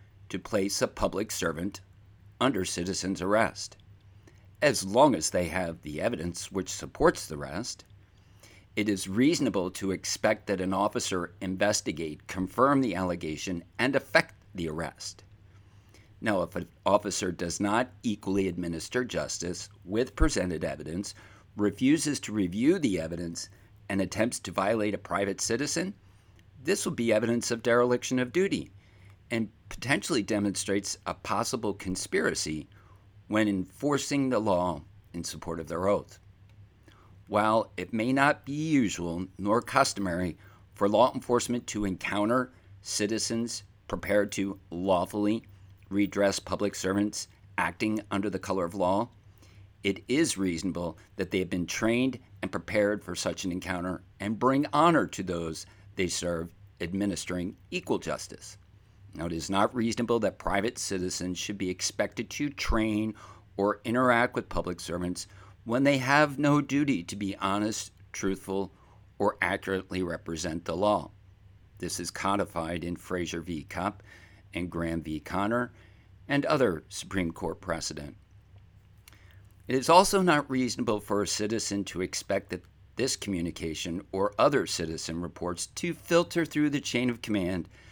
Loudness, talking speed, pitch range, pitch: -29 LUFS, 140 wpm, 90-110 Hz, 100 Hz